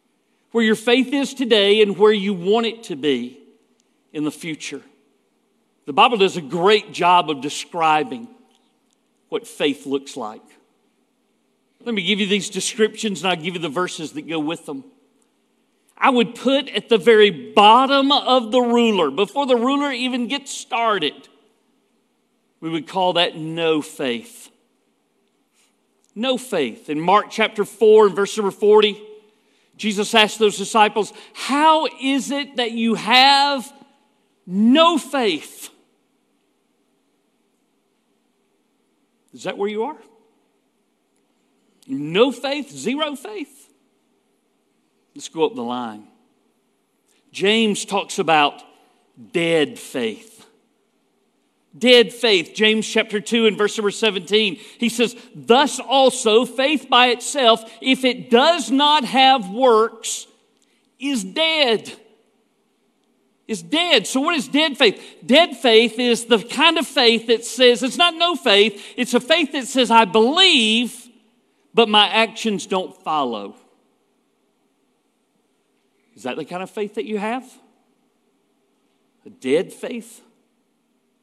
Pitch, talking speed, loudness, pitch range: 230 Hz, 130 wpm, -18 LUFS, 210-255 Hz